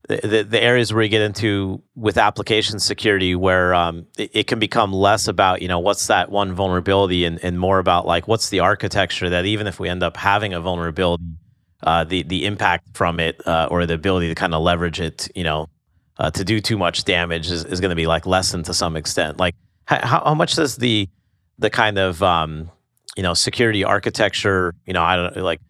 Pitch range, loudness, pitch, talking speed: 85-105 Hz, -19 LUFS, 95 Hz, 215 wpm